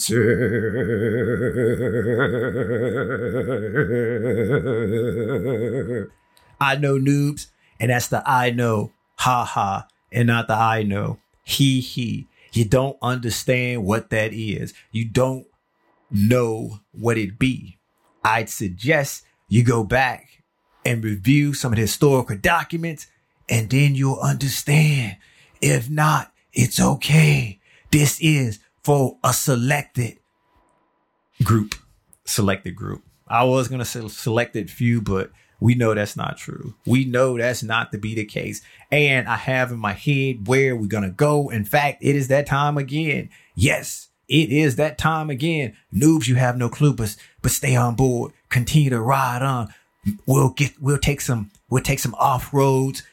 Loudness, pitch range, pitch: -21 LUFS, 115-140 Hz, 125 Hz